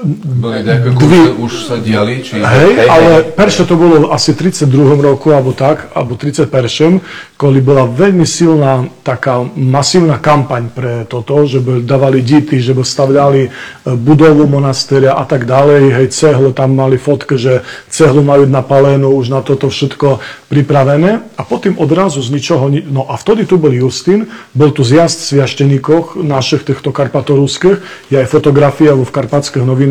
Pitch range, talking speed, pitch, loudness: 130-155 Hz, 155 wpm, 140 Hz, -9 LUFS